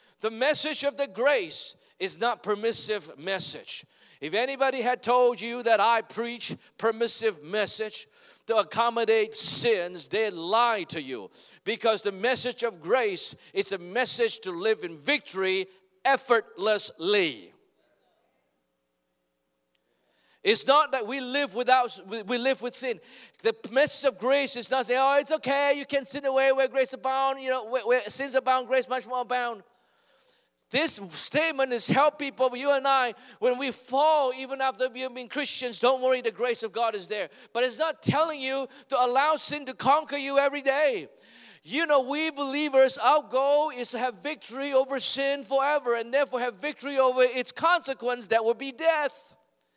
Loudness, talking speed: -26 LUFS, 165 wpm